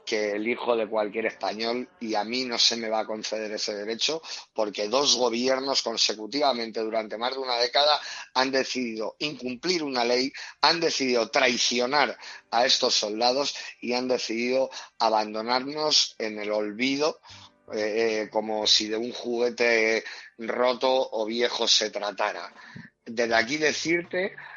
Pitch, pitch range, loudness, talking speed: 120 Hz, 110-130 Hz, -25 LUFS, 140 wpm